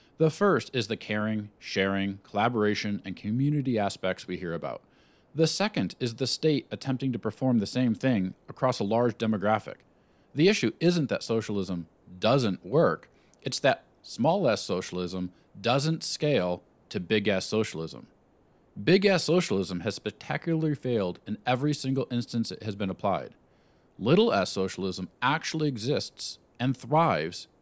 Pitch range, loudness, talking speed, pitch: 100-140 Hz, -28 LUFS, 145 wpm, 115 Hz